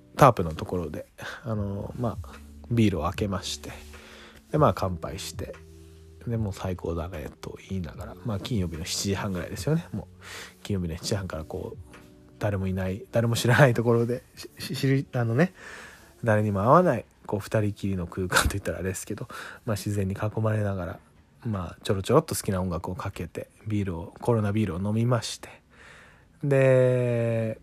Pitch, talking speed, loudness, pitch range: 100 Hz, 350 characters per minute, -27 LUFS, 90-115 Hz